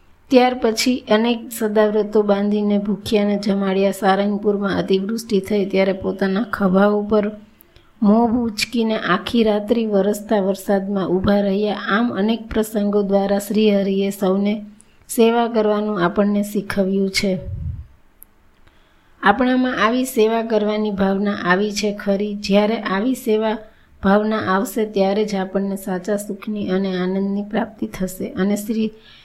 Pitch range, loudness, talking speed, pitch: 195-220 Hz, -19 LUFS, 105 wpm, 205 Hz